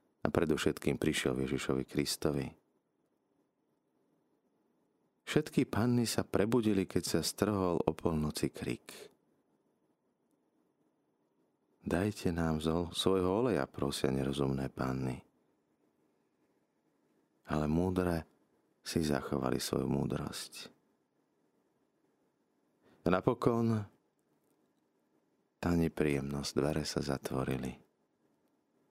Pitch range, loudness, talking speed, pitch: 70-90 Hz, -34 LUFS, 75 wpm, 80 Hz